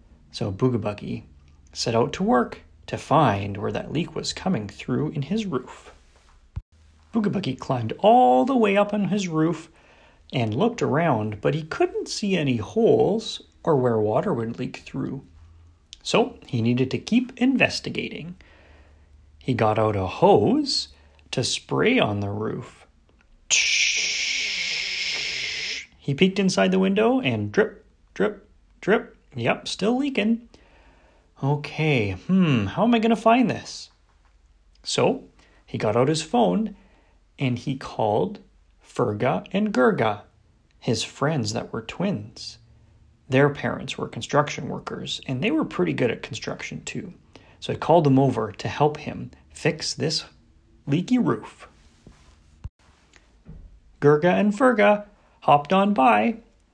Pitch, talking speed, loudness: 130 Hz, 130 wpm, -23 LUFS